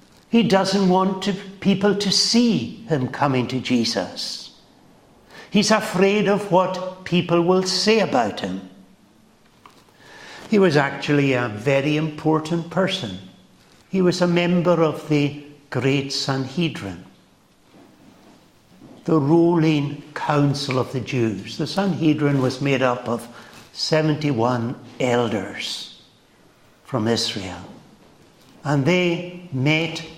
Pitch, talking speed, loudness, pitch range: 155 Hz, 105 wpm, -21 LUFS, 130-185 Hz